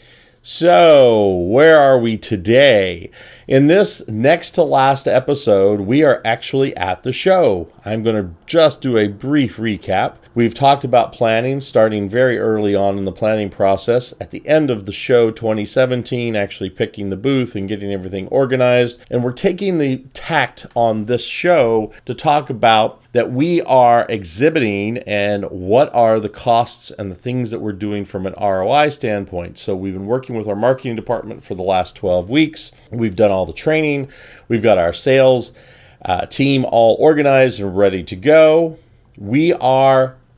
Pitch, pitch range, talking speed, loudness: 120 Hz, 105-135 Hz, 170 wpm, -15 LUFS